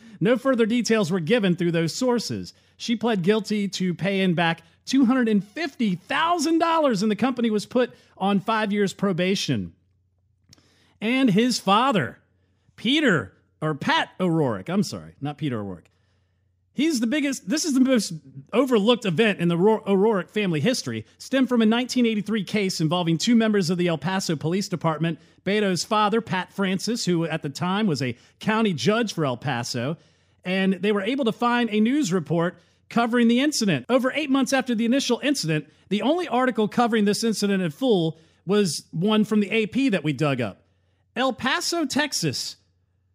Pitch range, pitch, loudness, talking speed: 160-235 Hz, 200 Hz, -23 LUFS, 165 wpm